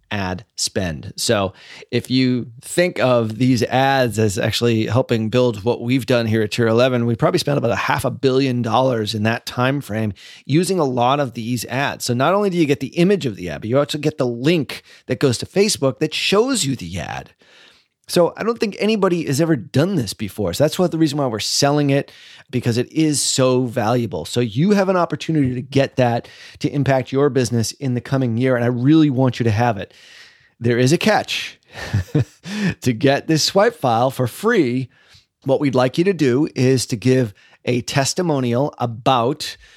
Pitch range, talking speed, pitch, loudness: 120-150 Hz, 205 wpm, 130 Hz, -18 LUFS